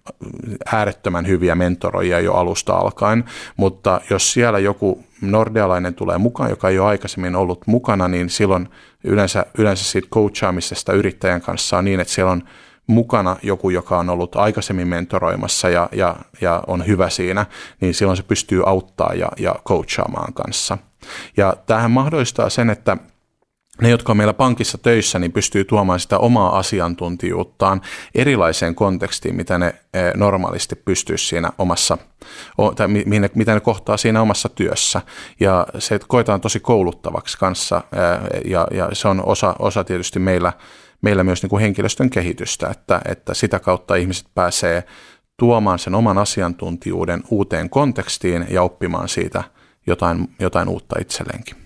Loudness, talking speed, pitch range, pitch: -18 LUFS, 145 wpm, 90-110 Hz, 95 Hz